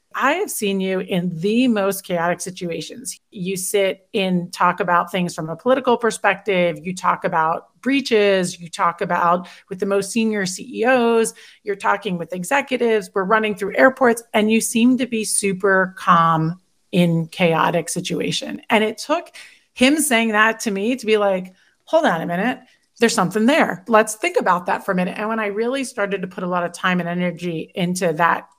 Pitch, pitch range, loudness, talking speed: 200 Hz, 180-225 Hz, -19 LUFS, 185 wpm